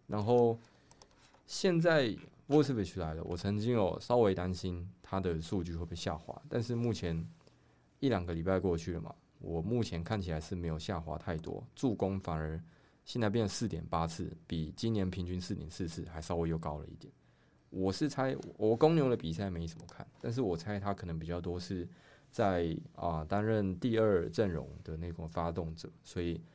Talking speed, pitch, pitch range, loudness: 275 characters per minute, 90 Hz, 85-110 Hz, -35 LUFS